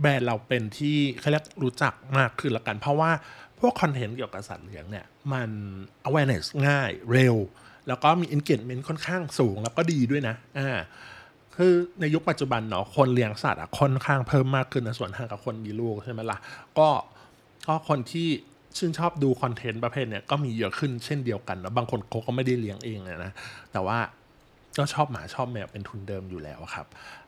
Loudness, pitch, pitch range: -27 LUFS, 130 Hz, 110-145 Hz